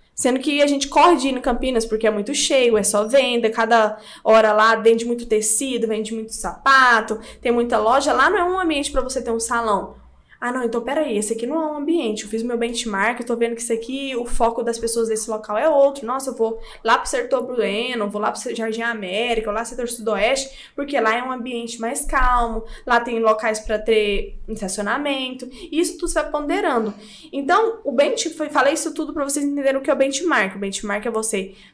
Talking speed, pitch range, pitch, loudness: 230 wpm, 220-275 Hz, 235 Hz, -20 LUFS